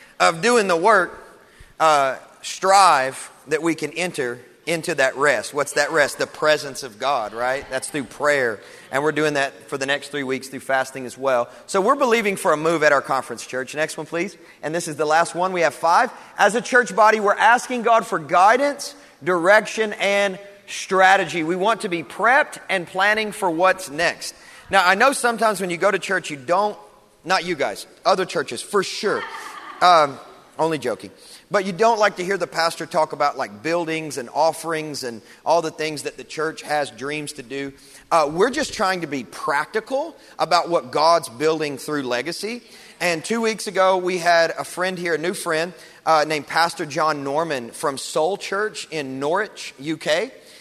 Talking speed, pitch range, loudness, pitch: 195 wpm, 150-195 Hz, -20 LUFS, 165 Hz